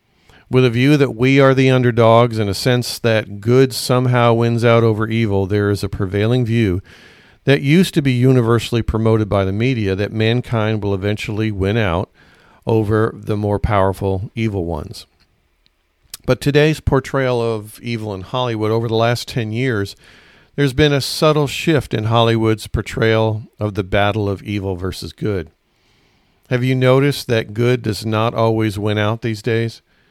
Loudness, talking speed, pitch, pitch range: -17 LUFS, 165 wpm, 110 Hz, 105-125 Hz